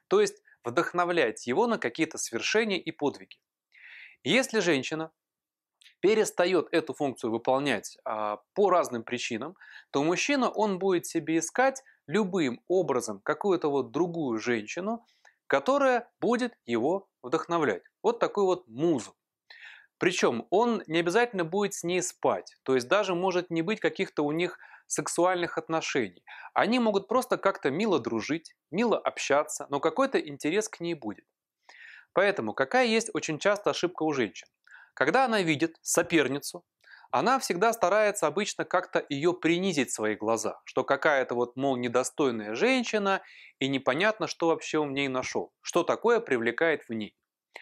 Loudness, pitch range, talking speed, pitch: -28 LUFS, 145-210 Hz, 140 wpm, 170 Hz